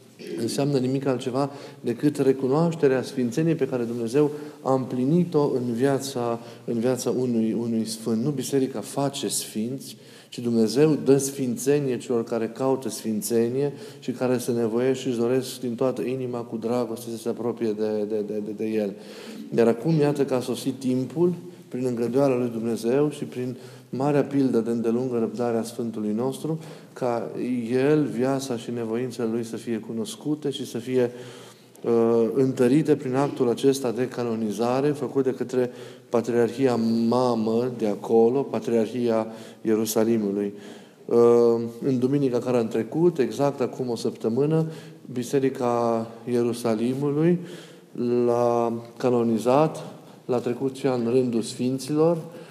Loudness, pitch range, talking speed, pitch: -24 LUFS, 115-135 Hz, 135 wpm, 125 Hz